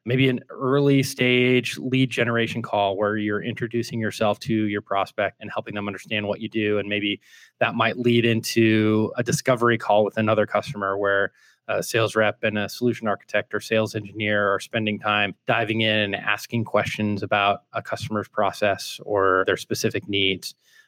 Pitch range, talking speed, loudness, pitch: 105-120 Hz, 170 wpm, -23 LUFS, 110 Hz